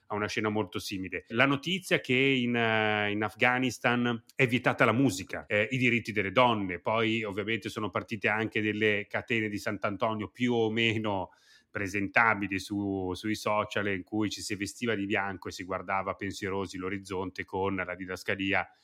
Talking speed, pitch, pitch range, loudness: 170 wpm, 105 Hz, 100-115 Hz, -29 LUFS